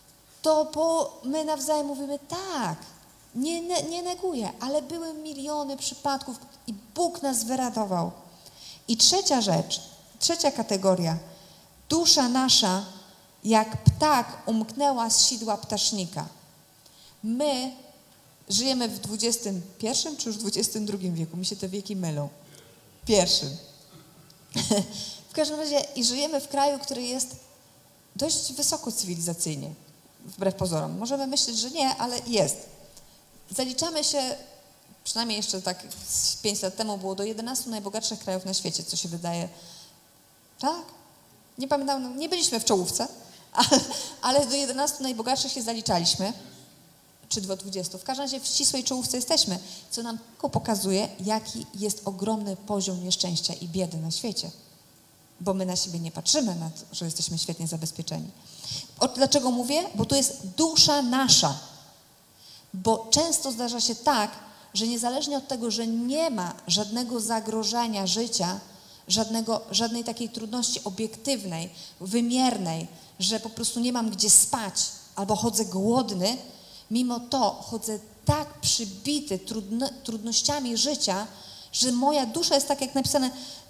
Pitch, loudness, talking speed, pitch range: 225 Hz, -26 LUFS, 130 wpm, 190-275 Hz